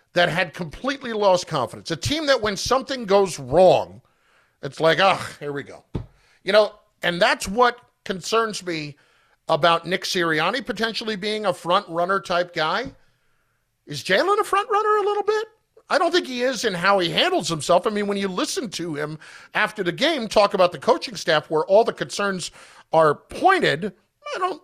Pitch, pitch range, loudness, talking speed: 195 Hz, 170-245 Hz, -21 LUFS, 190 wpm